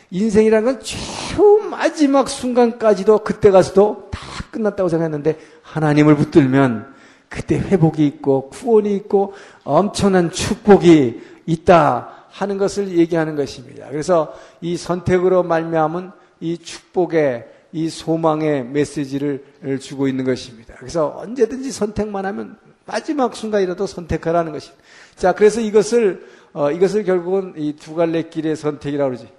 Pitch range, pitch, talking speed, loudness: 150-205 Hz, 175 Hz, 325 characters per minute, -17 LUFS